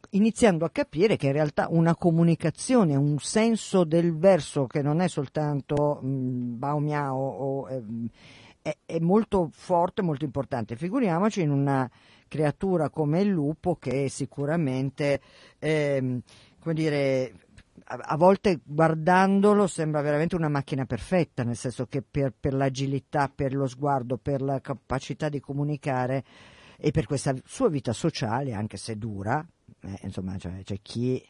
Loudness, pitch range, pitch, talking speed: -26 LUFS, 130-160 Hz, 145 Hz, 145 wpm